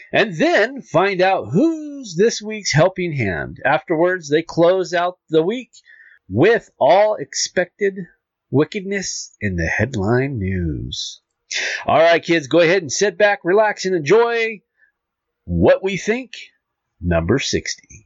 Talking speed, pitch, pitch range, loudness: 130 wpm, 180 Hz, 155-210 Hz, -18 LUFS